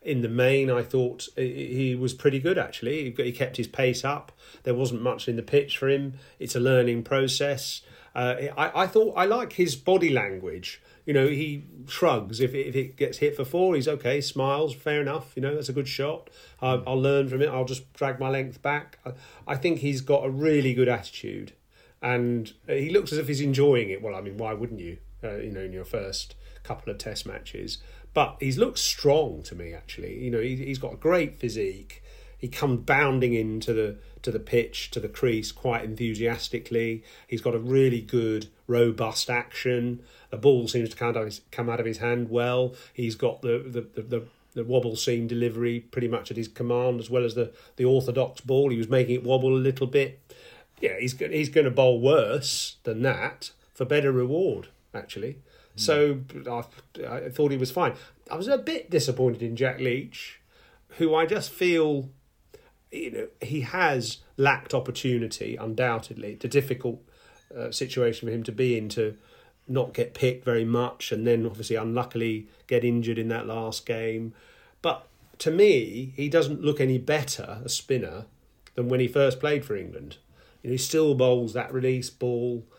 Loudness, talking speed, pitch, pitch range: -26 LUFS, 195 wpm, 125 Hz, 115-140 Hz